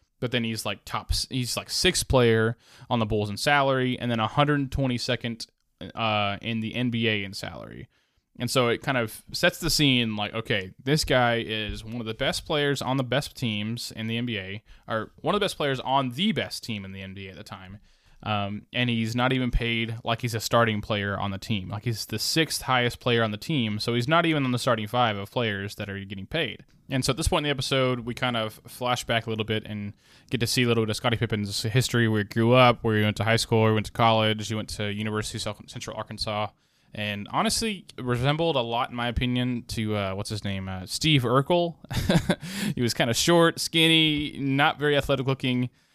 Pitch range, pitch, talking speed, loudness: 110-130 Hz, 120 Hz, 230 wpm, -25 LUFS